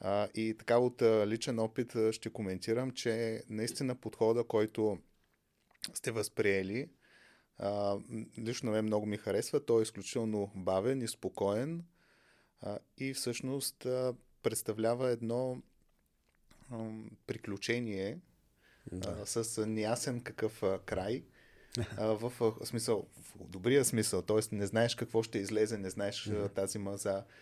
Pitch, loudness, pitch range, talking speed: 110 Hz, -35 LUFS, 105-120 Hz, 125 wpm